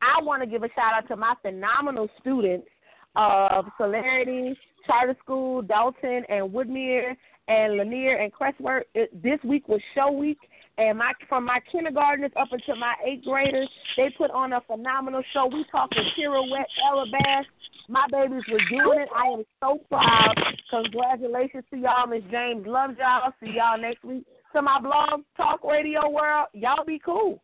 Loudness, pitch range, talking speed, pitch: -24 LUFS, 235-280 Hz, 170 wpm, 260 Hz